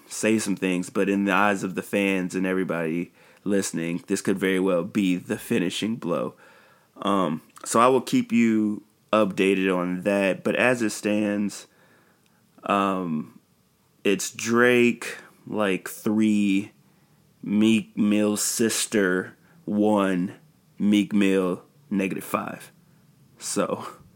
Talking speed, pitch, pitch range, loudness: 120 wpm, 100 Hz, 95-105 Hz, -24 LUFS